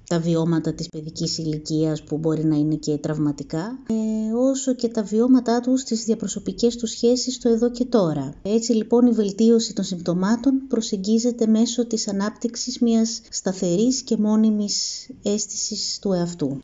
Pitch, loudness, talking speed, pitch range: 220 Hz, -22 LUFS, 150 wpm, 170-235 Hz